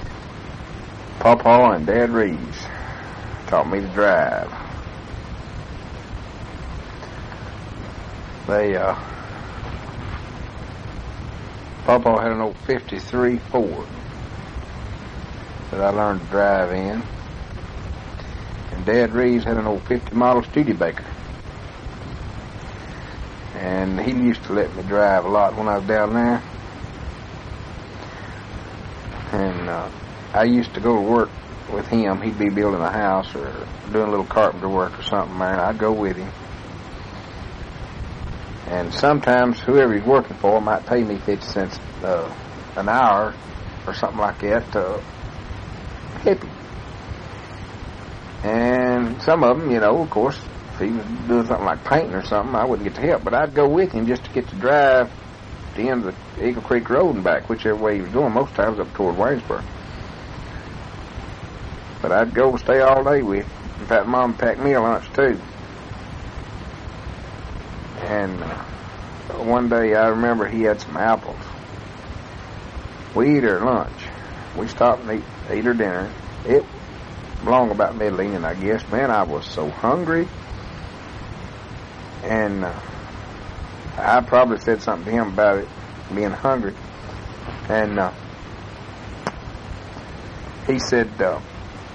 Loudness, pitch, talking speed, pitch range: -20 LUFS, 105 Hz, 140 wpm, 95-115 Hz